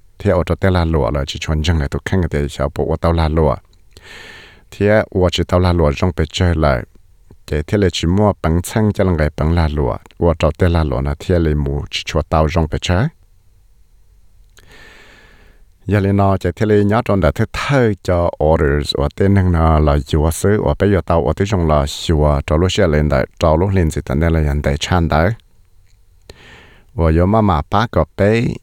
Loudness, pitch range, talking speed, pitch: -16 LUFS, 75-95 Hz, 110 wpm, 85 Hz